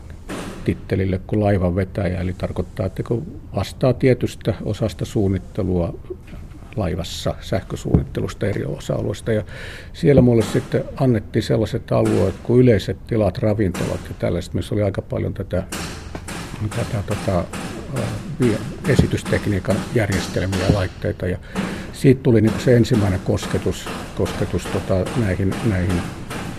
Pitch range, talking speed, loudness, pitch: 90-110 Hz, 120 wpm, -21 LUFS, 100 Hz